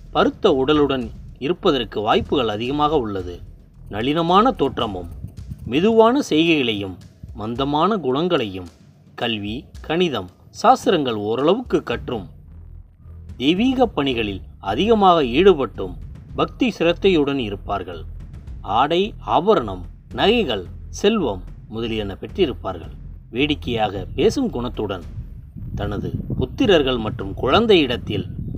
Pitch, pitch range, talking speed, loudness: 110 Hz, 90-150 Hz, 80 wpm, -20 LUFS